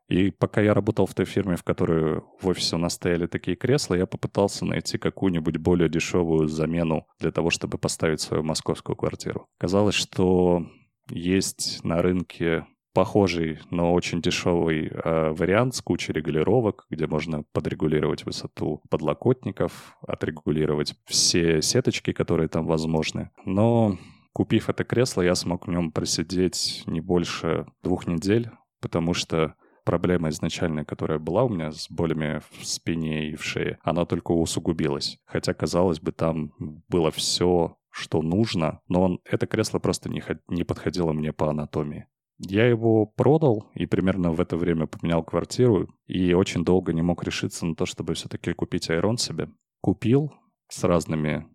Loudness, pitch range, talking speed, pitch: -25 LUFS, 80-95 Hz, 150 wpm, 85 Hz